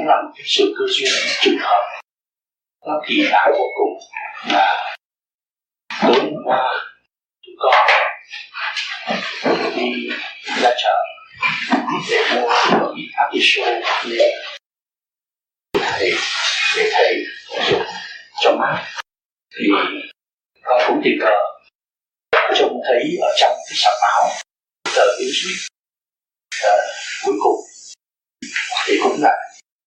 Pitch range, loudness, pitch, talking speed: 370-430 Hz, -17 LUFS, 390 Hz, 115 wpm